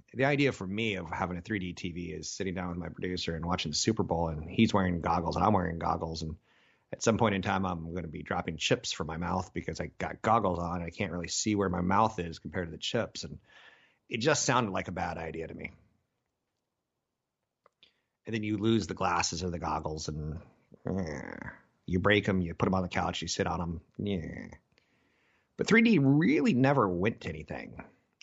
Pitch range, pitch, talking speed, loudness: 85-105 Hz, 90 Hz, 220 wpm, -31 LUFS